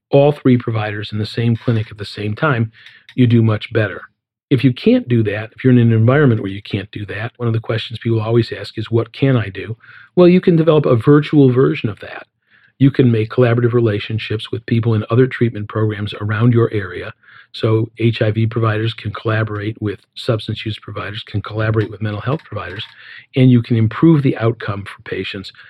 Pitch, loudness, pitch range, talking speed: 115 Hz, -16 LUFS, 105-125 Hz, 205 wpm